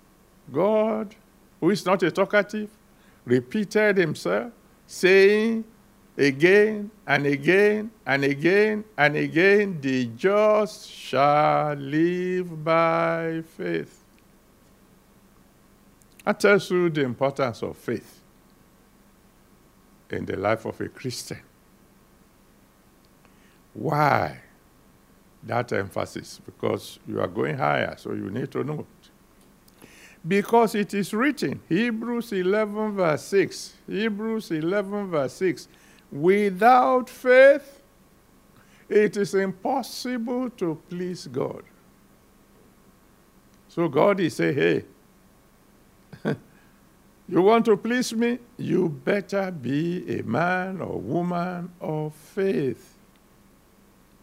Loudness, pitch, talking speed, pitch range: -23 LUFS, 195 Hz, 95 wpm, 165-215 Hz